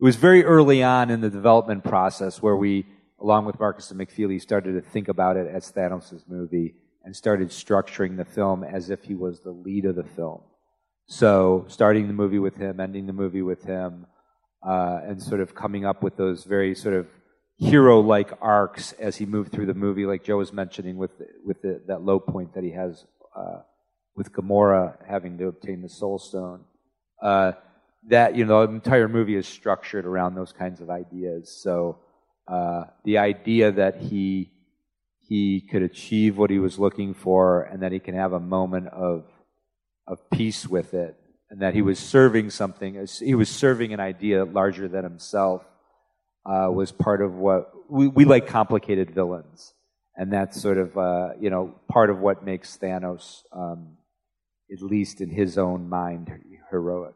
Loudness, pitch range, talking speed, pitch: -23 LUFS, 90-105 Hz, 185 wpm, 95 Hz